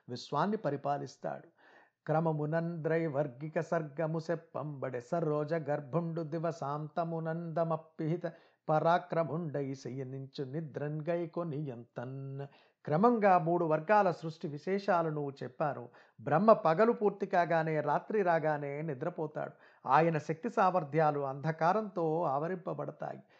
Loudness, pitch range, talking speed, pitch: -33 LUFS, 145-170 Hz, 75 wpm, 160 Hz